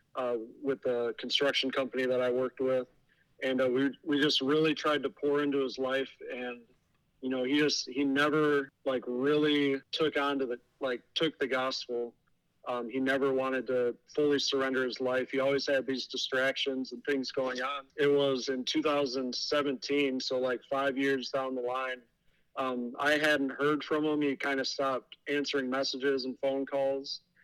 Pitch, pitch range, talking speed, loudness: 135 Hz, 130-140 Hz, 180 wpm, -31 LUFS